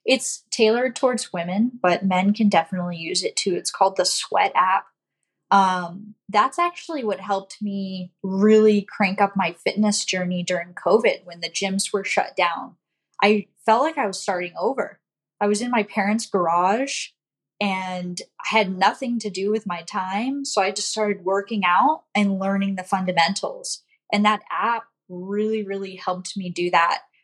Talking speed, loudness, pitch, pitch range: 170 wpm, -22 LUFS, 200 Hz, 185-215 Hz